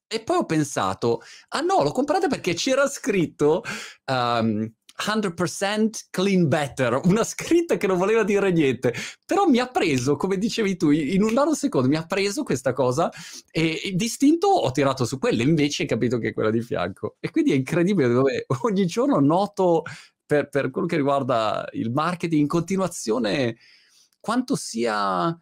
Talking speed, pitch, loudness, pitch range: 170 wpm, 175 Hz, -23 LUFS, 140-215 Hz